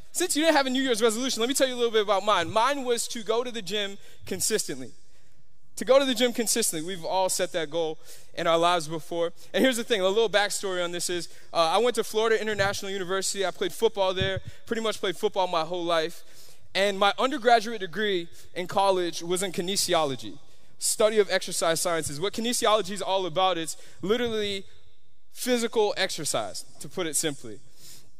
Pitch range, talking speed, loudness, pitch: 175-230 Hz, 200 wpm, -26 LUFS, 195 Hz